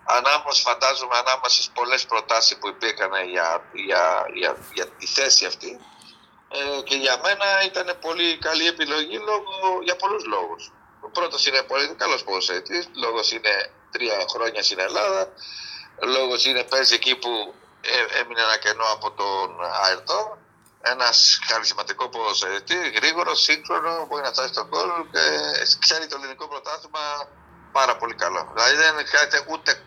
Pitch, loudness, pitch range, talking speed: 160 Hz, -21 LUFS, 135-195 Hz, 145 wpm